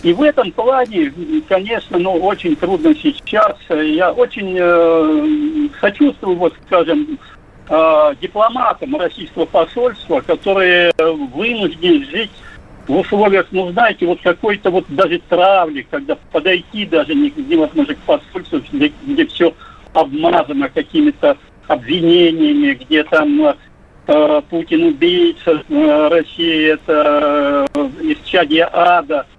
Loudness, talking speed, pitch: -14 LUFS, 110 wpm, 235 Hz